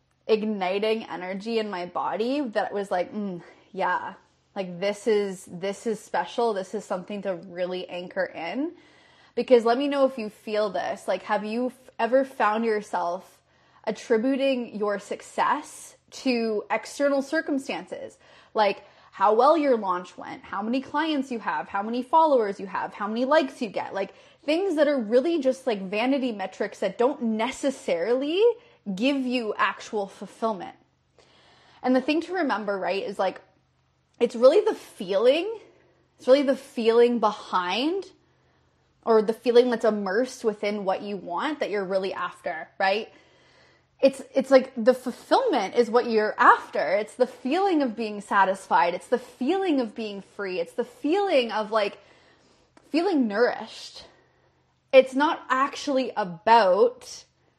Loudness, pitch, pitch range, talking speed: -25 LUFS, 235 Hz, 205-275 Hz, 150 wpm